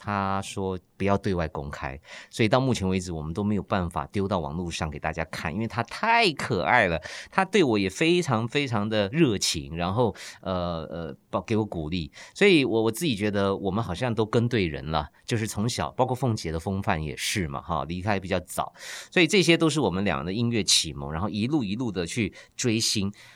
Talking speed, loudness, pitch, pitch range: 305 characters per minute, -26 LUFS, 100 Hz, 85-115 Hz